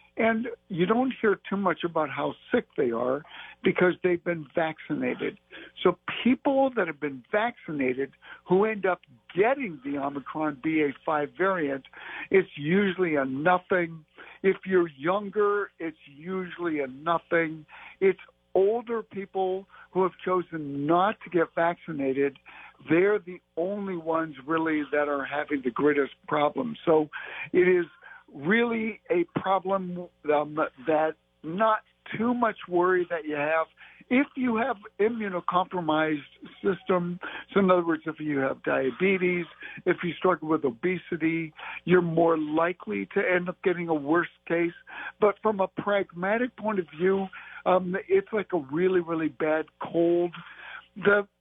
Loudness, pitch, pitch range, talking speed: -27 LUFS, 175 Hz, 155-195 Hz, 140 wpm